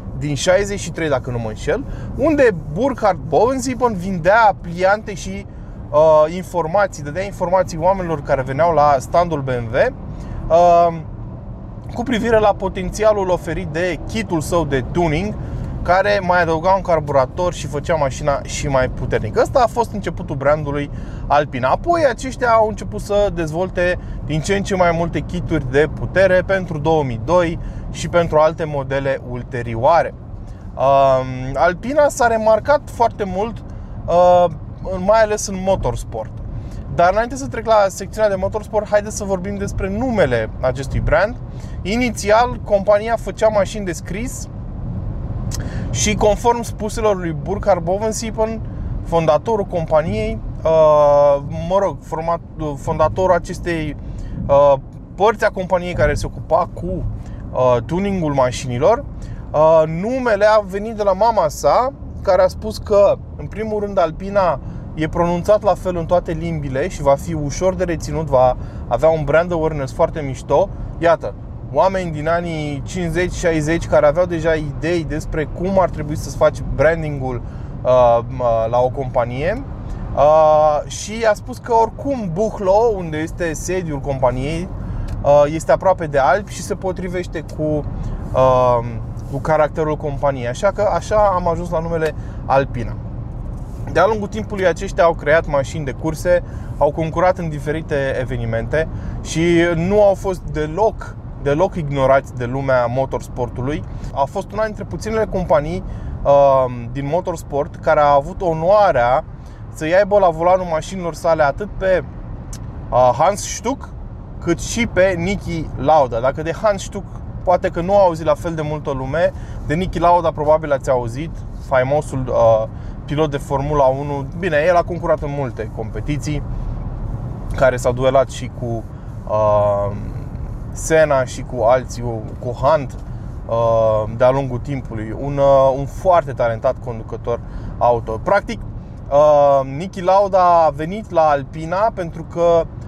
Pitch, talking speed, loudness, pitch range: 150 Hz, 135 wpm, -18 LUFS, 125-180 Hz